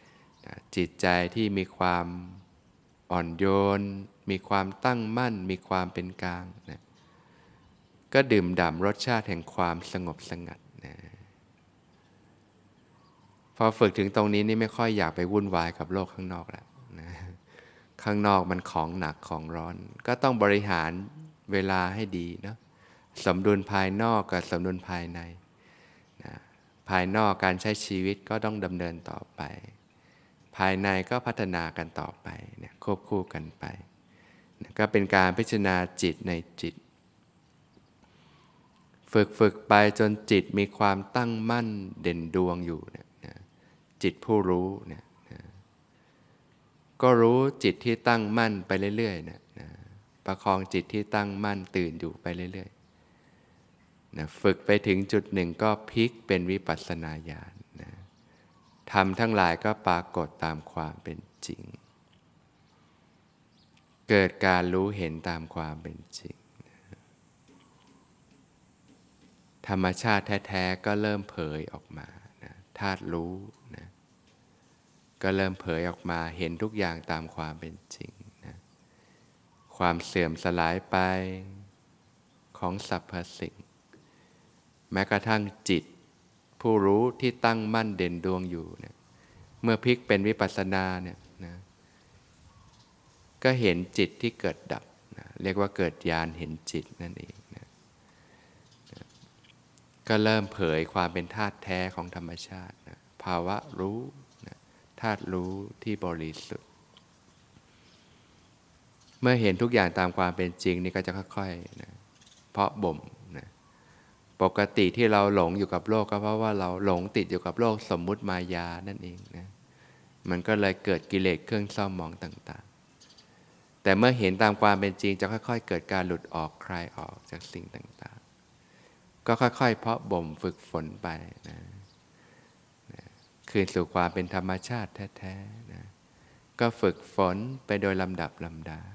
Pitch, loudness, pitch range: 95 Hz, -28 LUFS, 90-105 Hz